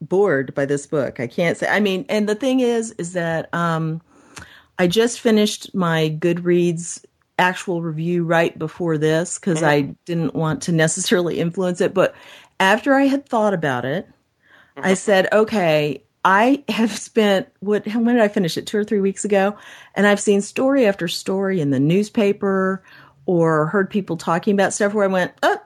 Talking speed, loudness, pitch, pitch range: 180 wpm, -19 LUFS, 190 Hz, 165-210 Hz